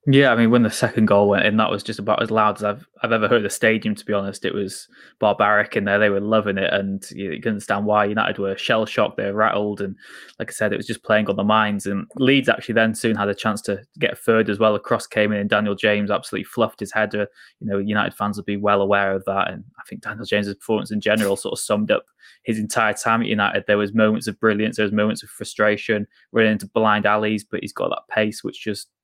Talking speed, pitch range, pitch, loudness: 270 wpm, 100-110 Hz, 105 Hz, -20 LUFS